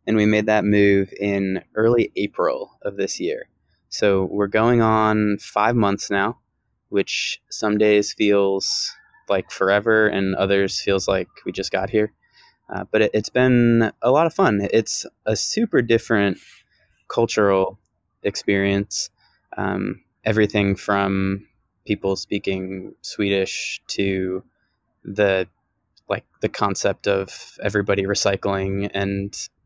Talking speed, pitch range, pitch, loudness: 125 wpm, 95-110 Hz, 100 Hz, -21 LUFS